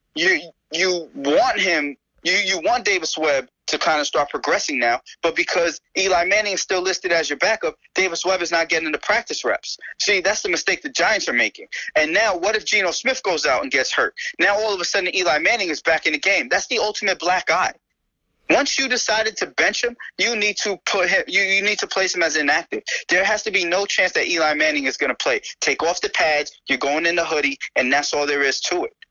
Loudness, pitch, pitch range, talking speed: -19 LUFS, 190 Hz, 165-240 Hz, 240 wpm